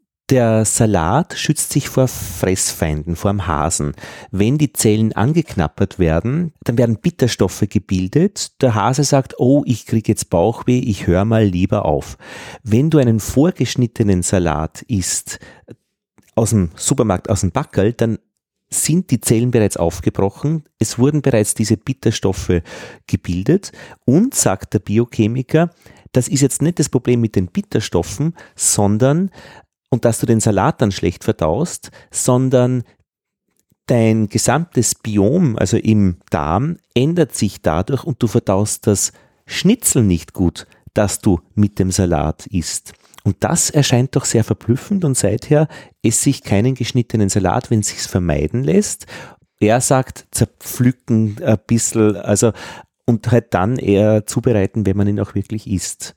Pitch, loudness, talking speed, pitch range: 110 Hz, -17 LUFS, 145 wpm, 100-130 Hz